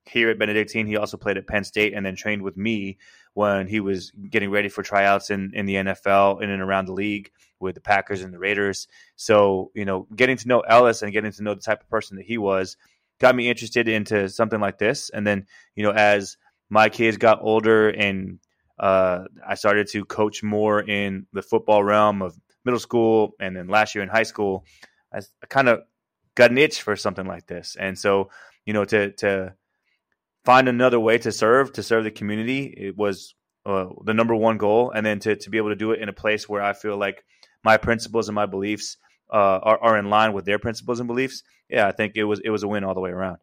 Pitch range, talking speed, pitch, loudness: 100-110 Hz, 230 wpm, 105 Hz, -21 LUFS